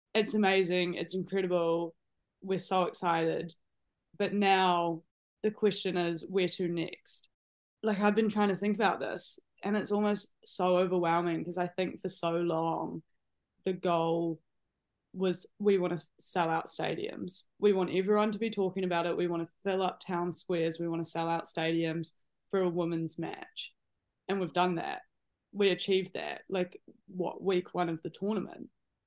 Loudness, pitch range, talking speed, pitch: -32 LUFS, 170-195 Hz, 170 wpm, 180 Hz